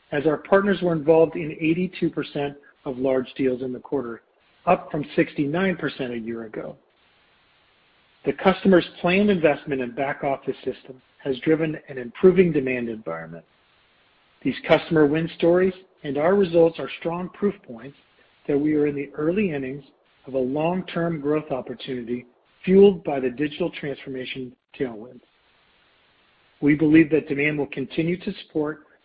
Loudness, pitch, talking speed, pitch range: -23 LUFS, 150 Hz, 145 wpm, 135-170 Hz